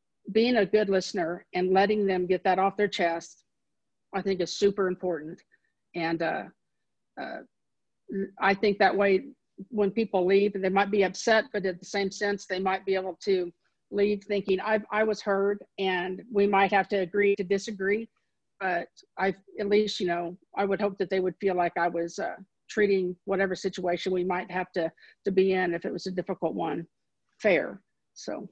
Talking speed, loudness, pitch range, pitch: 190 wpm, -27 LUFS, 185-205 Hz, 195 Hz